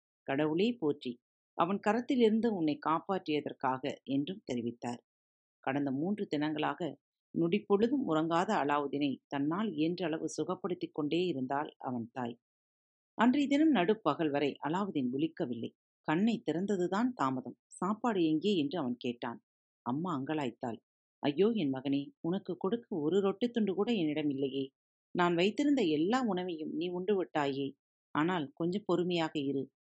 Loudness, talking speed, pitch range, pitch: -33 LUFS, 120 wpm, 140-200 Hz, 155 Hz